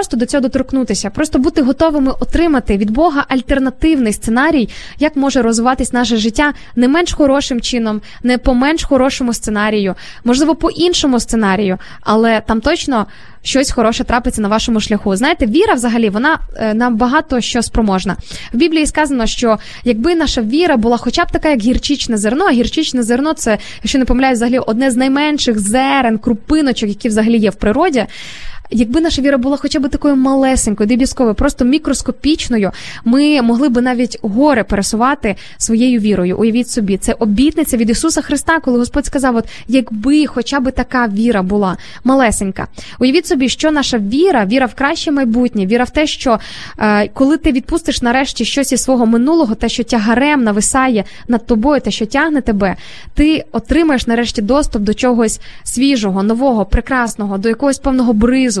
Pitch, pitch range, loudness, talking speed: 250 Hz, 230-280 Hz, -13 LUFS, 165 wpm